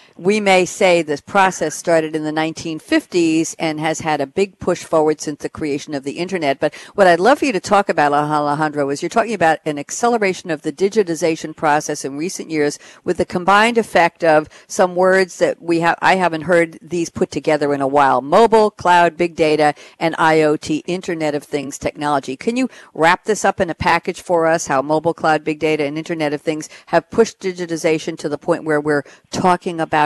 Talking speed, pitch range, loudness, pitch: 205 wpm, 155-185 Hz, -17 LUFS, 165 Hz